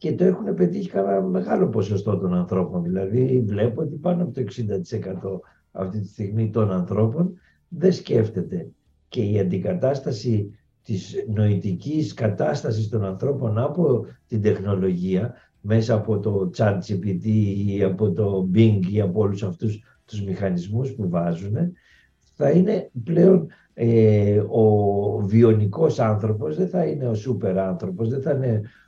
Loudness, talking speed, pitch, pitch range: -22 LUFS, 135 wpm, 110 Hz, 95-130 Hz